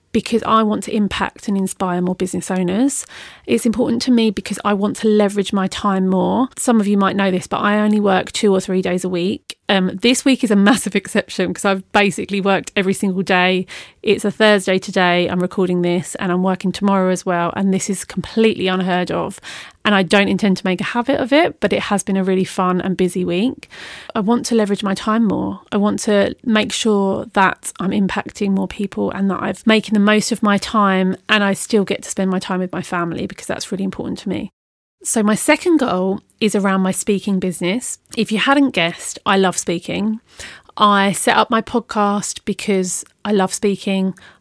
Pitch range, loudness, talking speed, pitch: 185-215 Hz, -17 LUFS, 215 wpm, 200 Hz